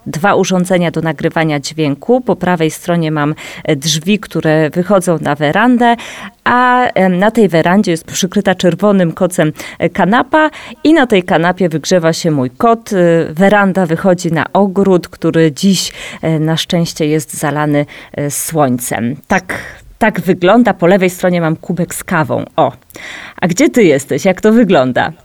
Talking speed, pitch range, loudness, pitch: 145 wpm, 160-200 Hz, -12 LUFS, 180 Hz